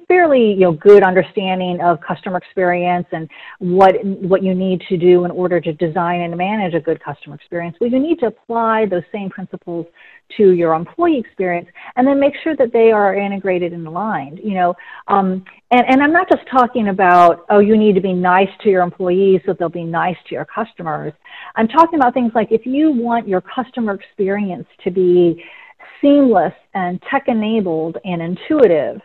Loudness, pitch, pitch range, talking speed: -15 LUFS, 190 Hz, 180-235 Hz, 190 wpm